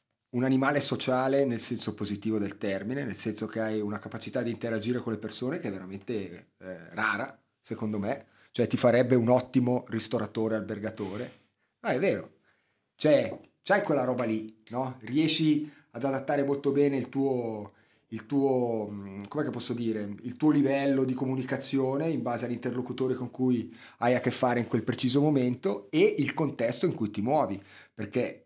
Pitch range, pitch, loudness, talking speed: 110-130 Hz, 125 Hz, -29 LUFS, 170 wpm